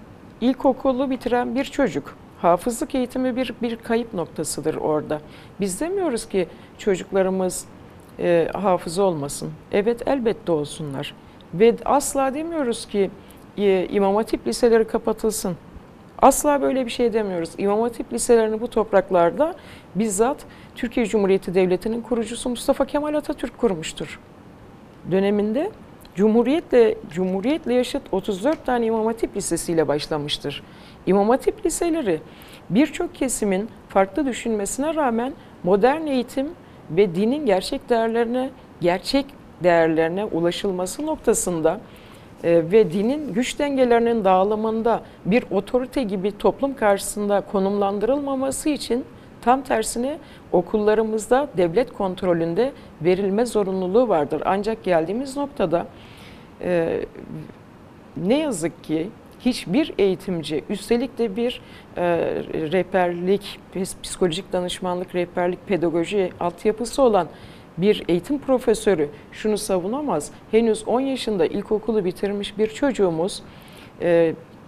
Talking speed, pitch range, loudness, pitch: 105 wpm, 185-255 Hz, -22 LUFS, 215 Hz